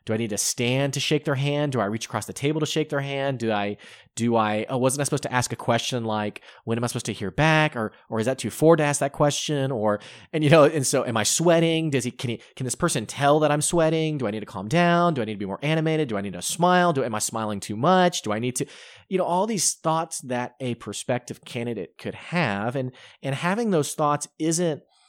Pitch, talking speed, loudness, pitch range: 135 Hz, 275 wpm, -24 LUFS, 115-155 Hz